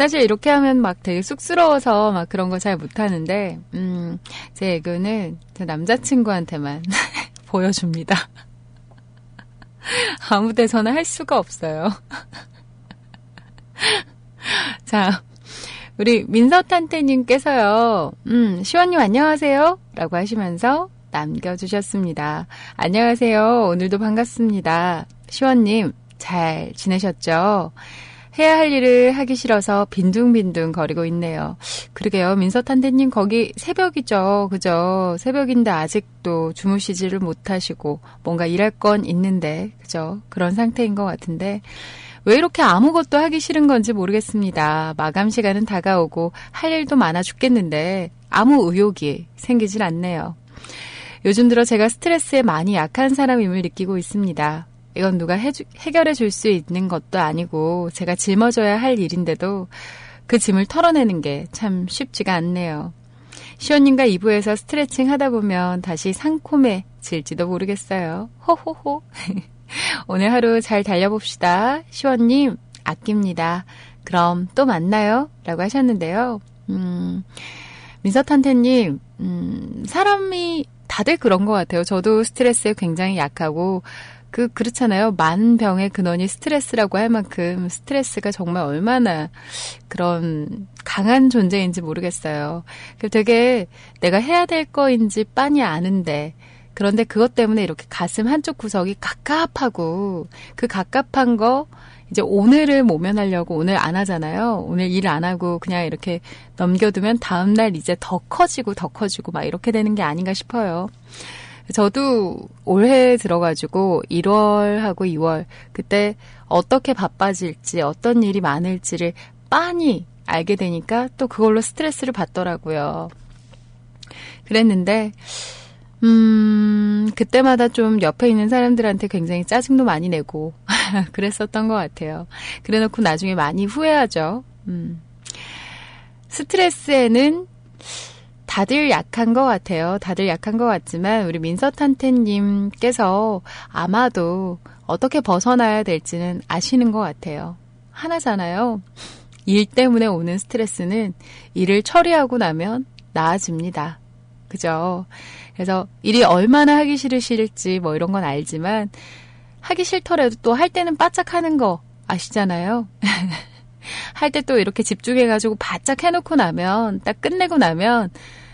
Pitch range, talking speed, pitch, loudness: 170-235 Hz, 280 characters per minute, 200 Hz, -18 LUFS